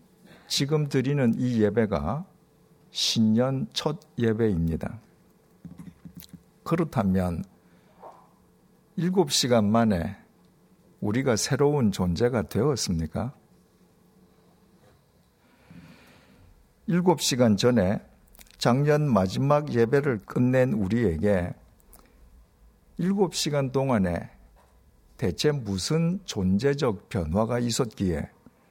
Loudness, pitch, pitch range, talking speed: -25 LUFS, 120 Hz, 100-150 Hz, 170 characters per minute